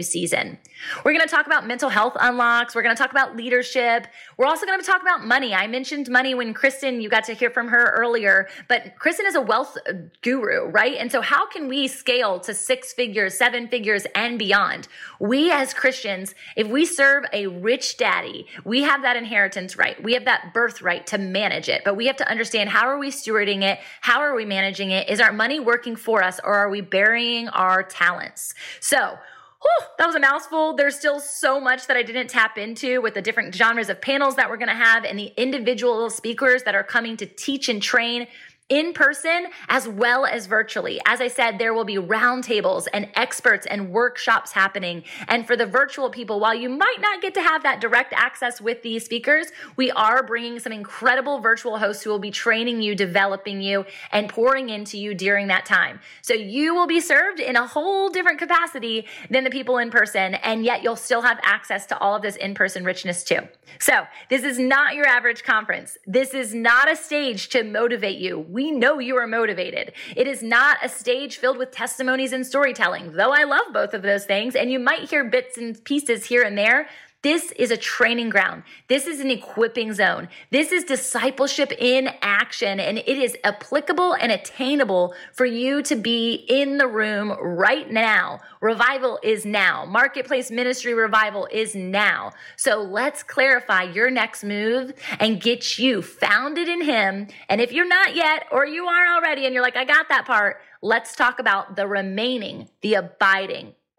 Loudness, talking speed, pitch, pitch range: -20 LUFS, 200 wpm, 240 Hz, 210-270 Hz